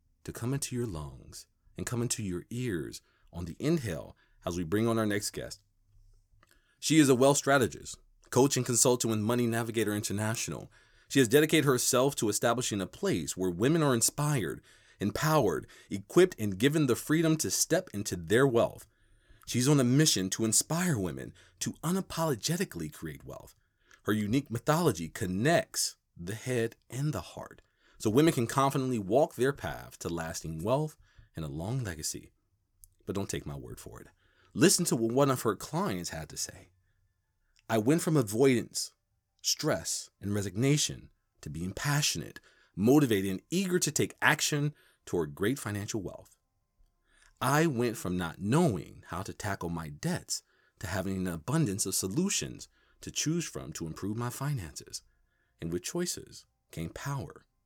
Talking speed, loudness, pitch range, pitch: 160 wpm, -30 LUFS, 95-140 Hz, 115 Hz